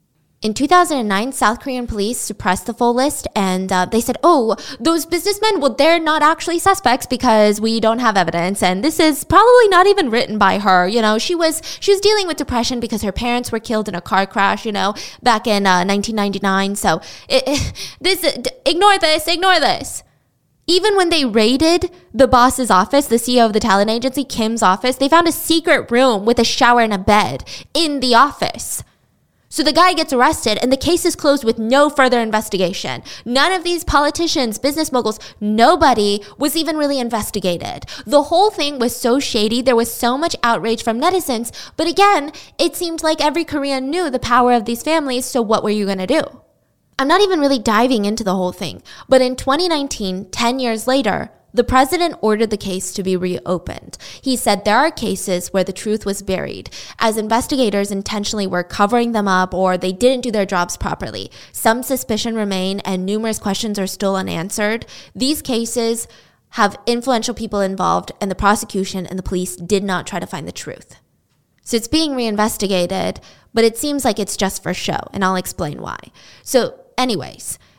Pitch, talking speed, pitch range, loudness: 235 Hz, 190 wpm, 205-290 Hz, -16 LUFS